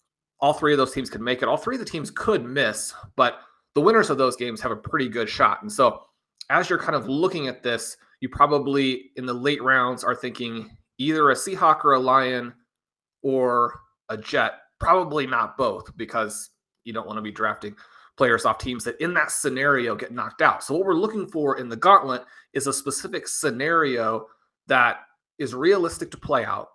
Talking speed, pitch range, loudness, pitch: 200 wpm, 120-140 Hz, -23 LUFS, 130 Hz